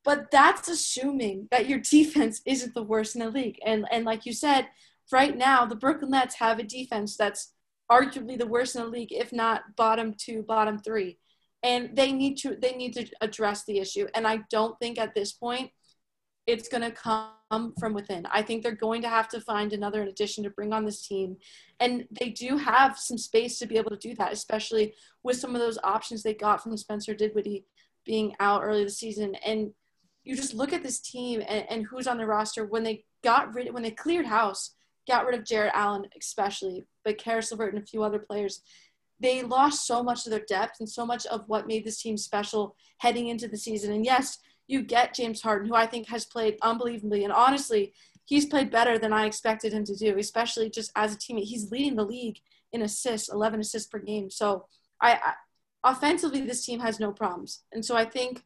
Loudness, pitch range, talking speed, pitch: -28 LUFS, 215-245 Hz, 215 wpm, 225 Hz